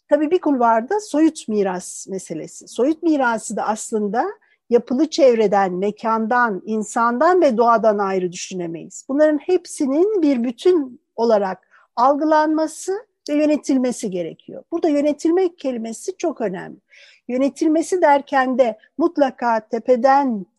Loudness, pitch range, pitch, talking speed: -19 LUFS, 225-315 Hz, 265 Hz, 110 wpm